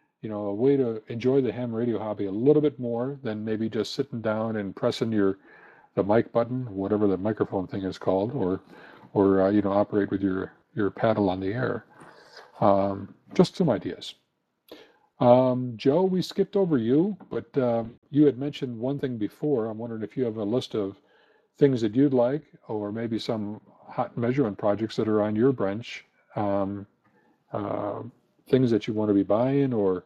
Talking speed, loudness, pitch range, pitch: 190 wpm, -26 LUFS, 100-130 Hz, 110 Hz